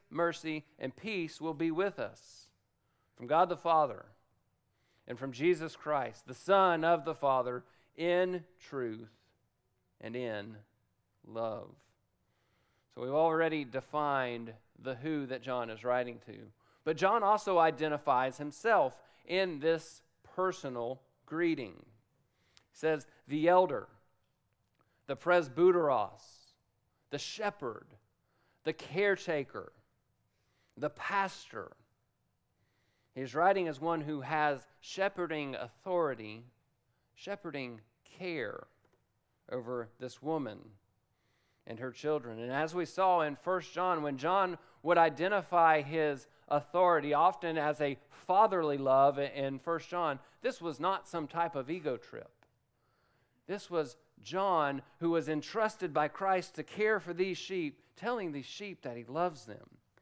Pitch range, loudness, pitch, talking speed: 120-170 Hz, -33 LUFS, 150 Hz, 120 wpm